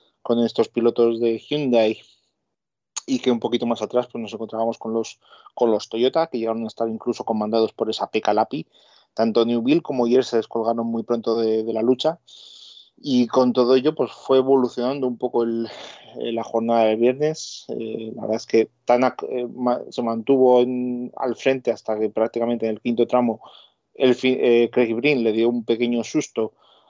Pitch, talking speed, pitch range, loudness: 120 Hz, 185 wpm, 115-125 Hz, -21 LUFS